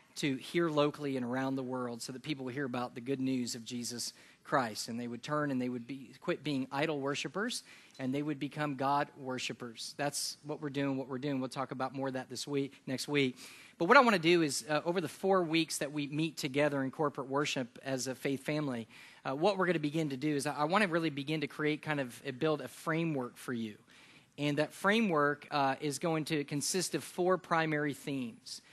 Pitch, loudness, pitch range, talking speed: 145 Hz, -34 LUFS, 130-155 Hz, 240 wpm